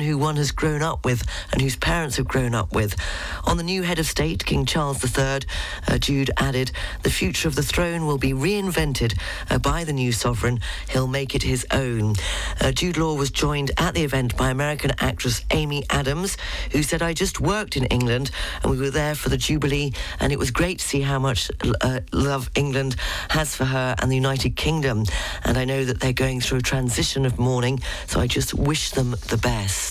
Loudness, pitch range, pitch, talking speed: -23 LUFS, 125-150 Hz, 135 Hz, 215 wpm